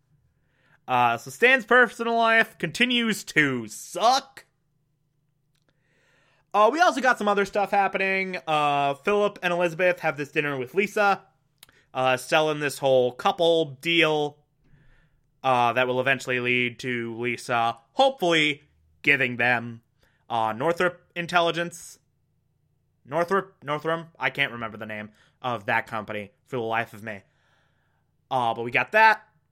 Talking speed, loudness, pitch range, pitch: 130 wpm, -23 LUFS, 125-180 Hz, 145 Hz